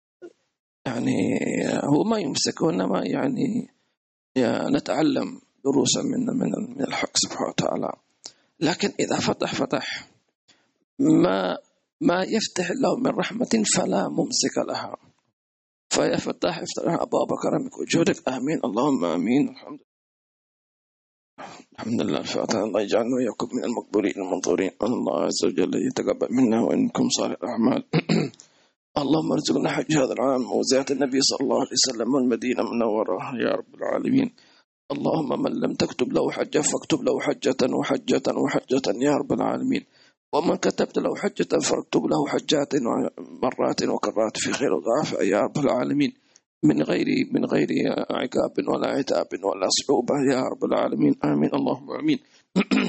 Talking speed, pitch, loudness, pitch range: 130 wpm, 250 Hz, -24 LUFS, 225-275 Hz